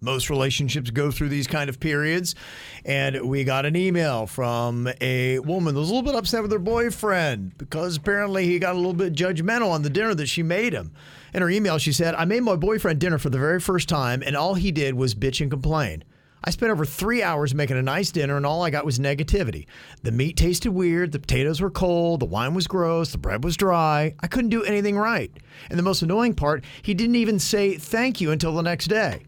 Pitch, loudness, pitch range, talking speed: 165 Hz, -23 LUFS, 140-190 Hz, 235 wpm